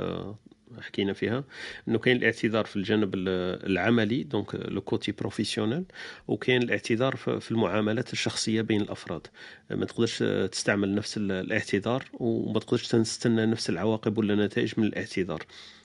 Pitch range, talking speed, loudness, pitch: 105-115 Hz, 120 wpm, -28 LUFS, 110 Hz